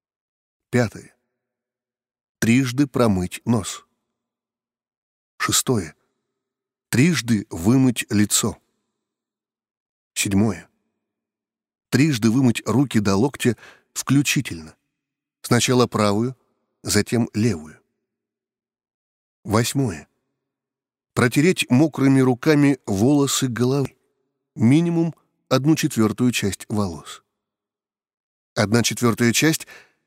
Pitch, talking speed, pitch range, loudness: 125 Hz, 65 wpm, 110-135 Hz, -20 LUFS